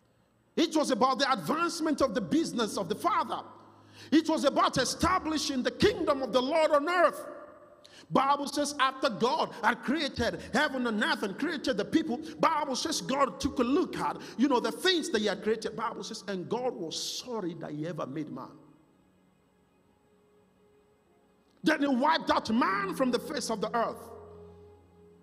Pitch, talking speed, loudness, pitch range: 270 Hz, 170 wpm, -29 LUFS, 225-300 Hz